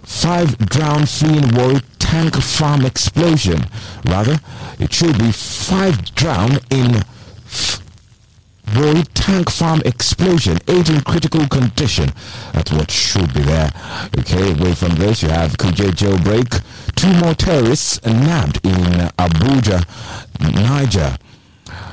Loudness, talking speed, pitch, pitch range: -15 LUFS, 115 wpm, 115 Hz, 95-145 Hz